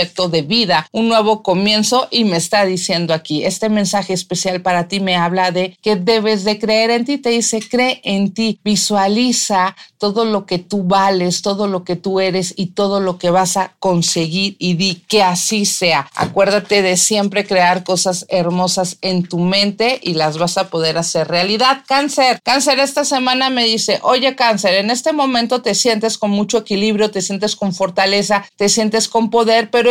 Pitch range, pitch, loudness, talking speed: 185-225 Hz, 200 Hz, -15 LUFS, 185 wpm